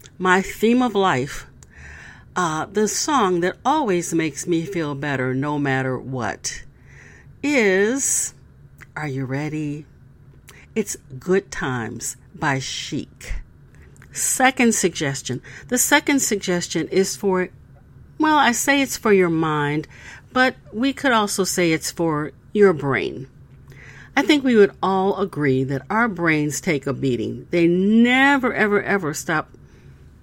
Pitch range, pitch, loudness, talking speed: 140-215 Hz, 175 Hz, -20 LUFS, 130 wpm